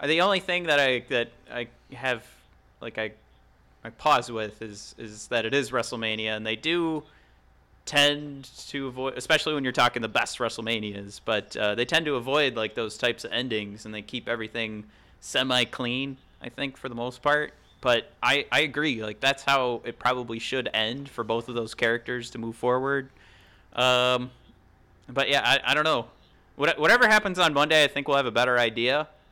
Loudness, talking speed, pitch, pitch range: -25 LUFS, 190 wpm, 125 Hz, 110-140 Hz